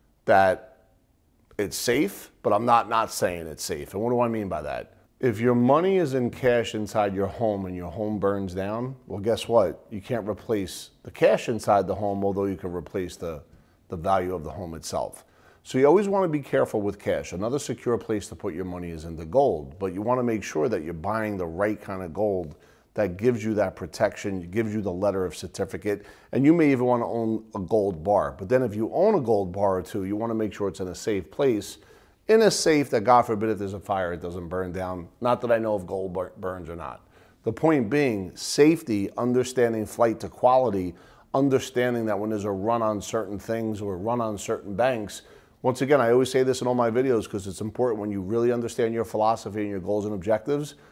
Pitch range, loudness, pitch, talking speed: 95-120 Hz, -25 LUFS, 110 Hz, 235 wpm